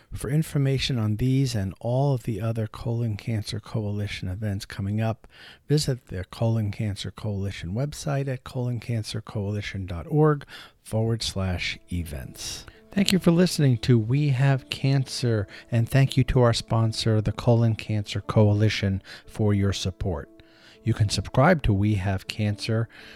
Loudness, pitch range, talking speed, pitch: -25 LUFS, 105-125 Hz, 140 wpm, 110 Hz